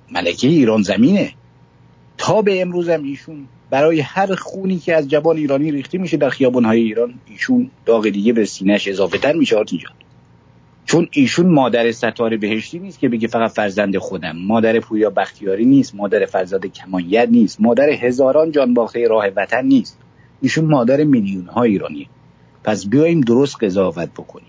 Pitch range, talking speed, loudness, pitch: 110-160 Hz, 155 wpm, -16 LUFS, 125 Hz